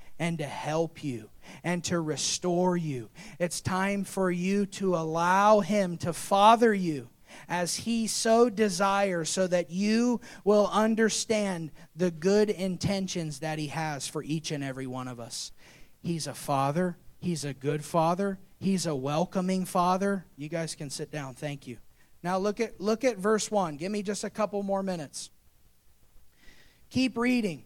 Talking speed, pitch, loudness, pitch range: 160 wpm, 180 Hz, -28 LUFS, 155-200 Hz